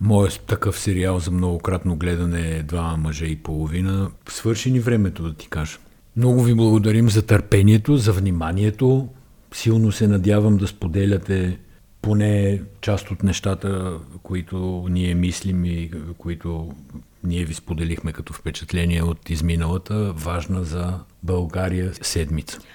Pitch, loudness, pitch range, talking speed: 90 Hz, -21 LUFS, 85-105 Hz, 130 wpm